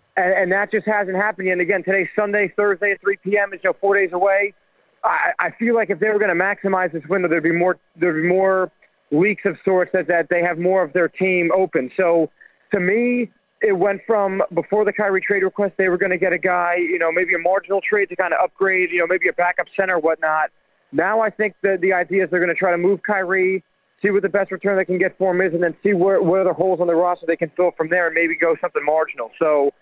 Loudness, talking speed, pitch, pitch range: -19 LUFS, 260 wpm, 190 Hz, 175-200 Hz